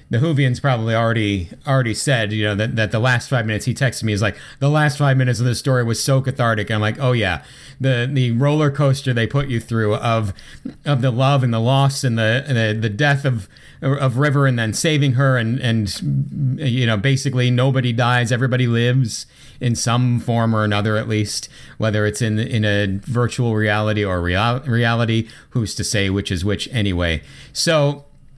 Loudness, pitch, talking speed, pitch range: -18 LUFS, 120 Hz, 205 wpm, 110-135 Hz